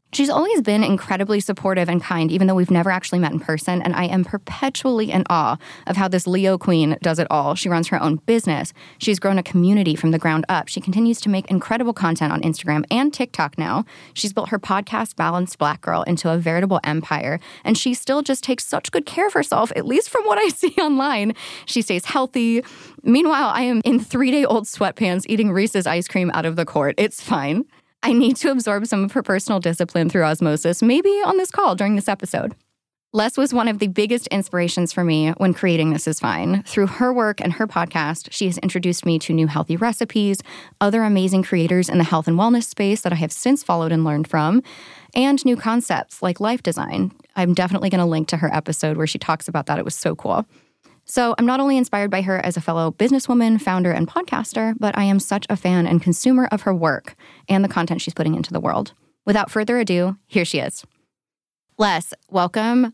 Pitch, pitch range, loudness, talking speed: 195 Hz, 170-230 Hz, -20 LUFS, 220 wpm